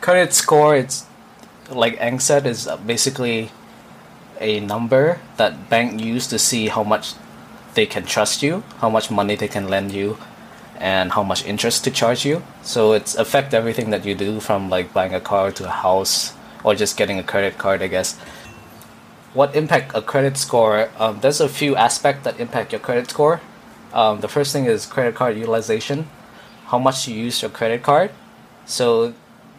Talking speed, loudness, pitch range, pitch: 175 wpm, -19 LUFS, 105-130 Hz, 115 Hz